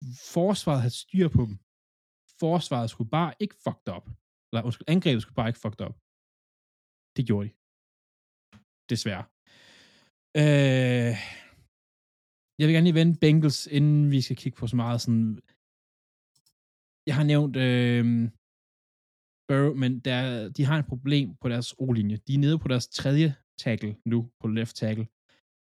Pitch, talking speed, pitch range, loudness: 125 Hz, 145 wpm, 110-145 Hz, -26 LUFS